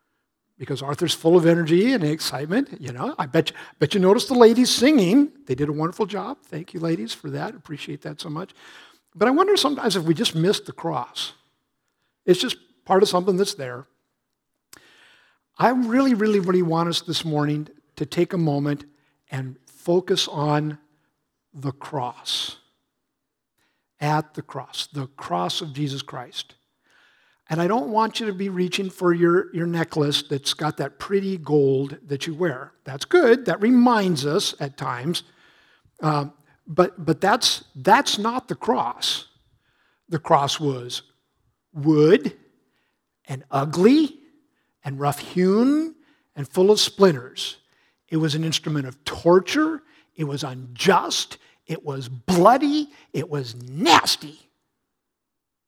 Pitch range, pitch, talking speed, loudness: 145-205 Hz, 165 Hz, 145 wpm, -21 LUFS